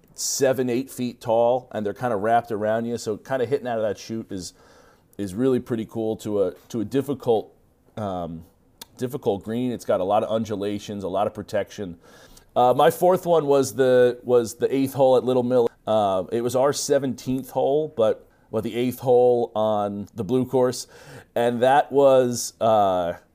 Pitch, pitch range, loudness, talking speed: 120 Hz, 110-130 Hz, -23 LUFS, 200 wpm